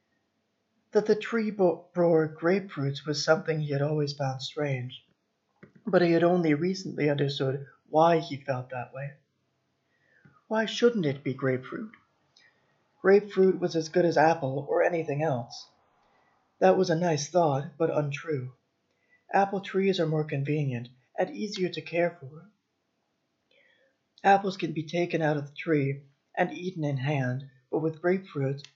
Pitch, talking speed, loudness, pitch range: 160 Hz, 145 wpm, -27 LUFS, 140-180 Hz